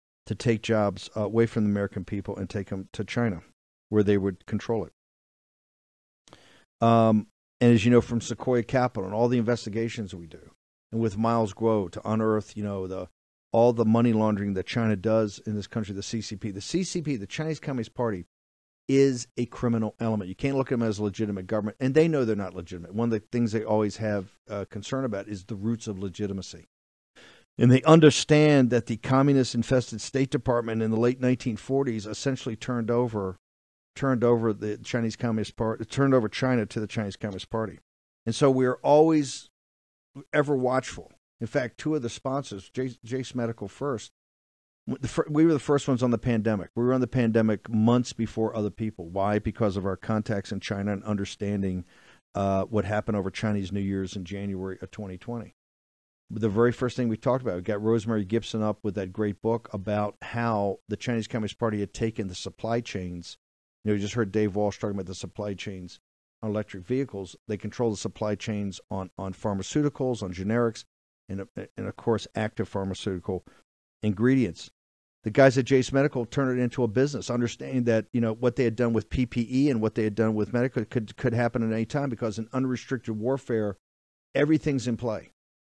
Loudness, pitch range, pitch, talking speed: -27 LUFS, 100-120 Hz, 110 Hz, 190 wpm